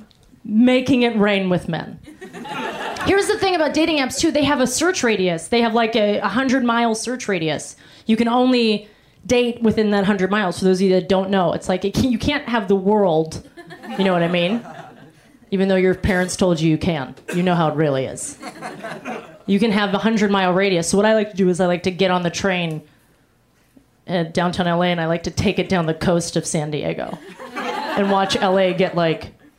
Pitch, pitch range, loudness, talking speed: 195 Hz, 175-235 Hz, -19 LUFS, 220 wpm